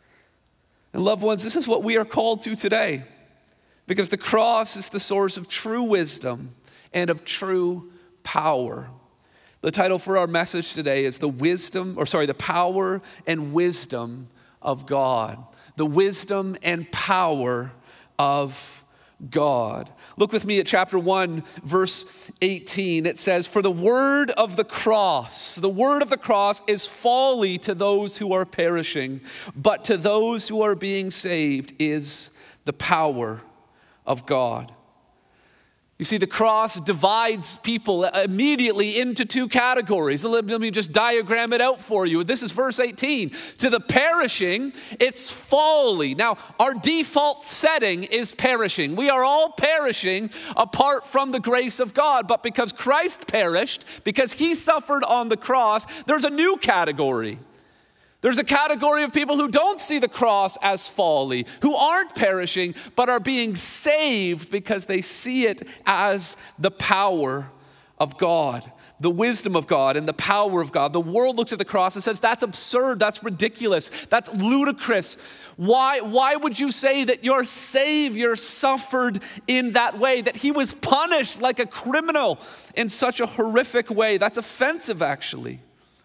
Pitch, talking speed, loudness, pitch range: 215 Hz, 155 wpm, -21 LUFS, 180-250 Hz